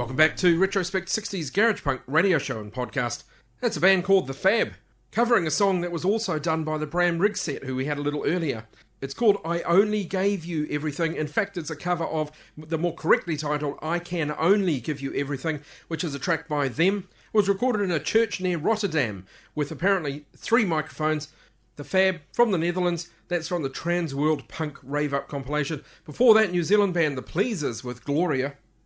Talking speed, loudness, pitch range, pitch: 205 wpm, -25 LUFS, 150-190 Hz, 165 Hz